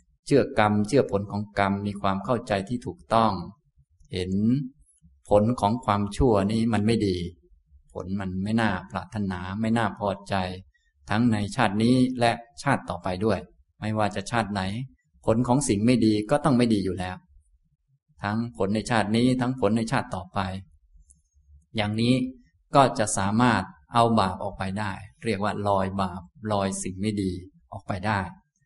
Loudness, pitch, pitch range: -25 LUFS, 100 Hz, 95-115 Hz